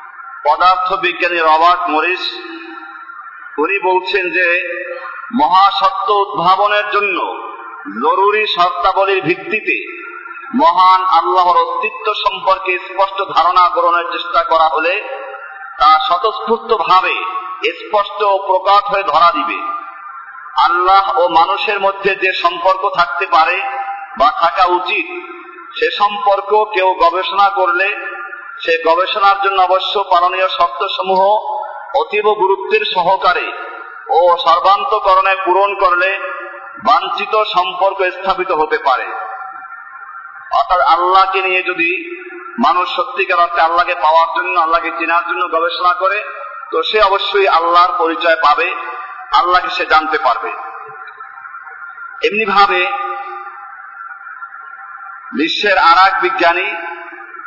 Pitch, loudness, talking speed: 195 Hz, -13 LUFS, 85 wpm